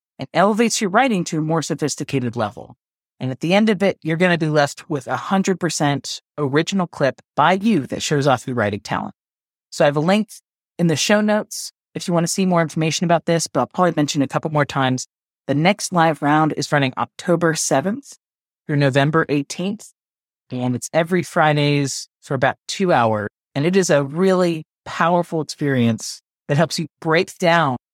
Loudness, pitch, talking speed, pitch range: -19 LUFS, 160 Hz, 195 wpm, 145-180 Hz